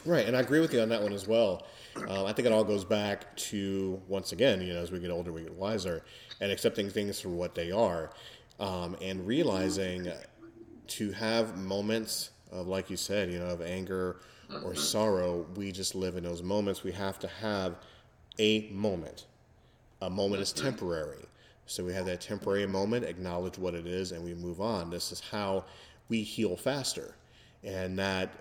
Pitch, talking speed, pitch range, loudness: 95 Hz, 190 wpm, 90-105 Hz, -33 LUFS